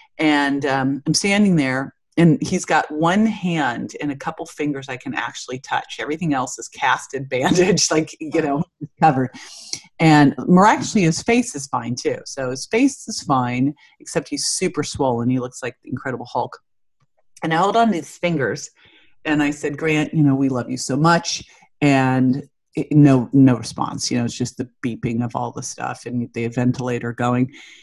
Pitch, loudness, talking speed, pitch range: 145 Hz, -20 LUFS, 185 wpm, 130-165 Hz